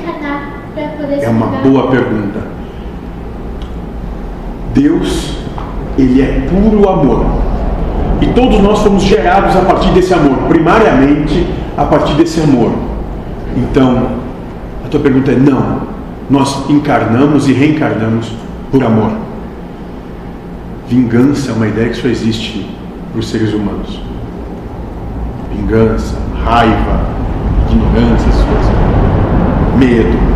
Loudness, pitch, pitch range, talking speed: -11 LUFS, 125 Hz, 110-145 Hz, 100 wpm